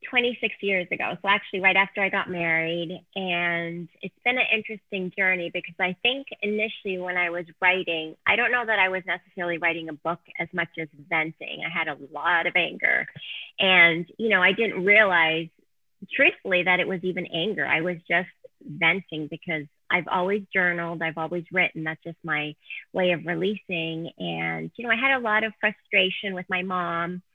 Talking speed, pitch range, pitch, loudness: 185 wpm, 170-195 Hz, 180 Hz, -24 LUFS